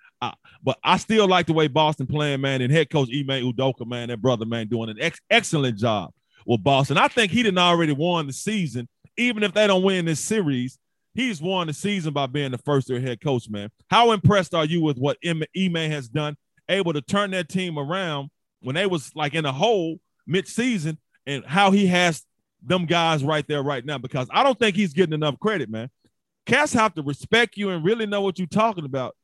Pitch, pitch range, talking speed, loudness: 160 Hz, 140-195 Hz, 220 wpm, -22 LUFS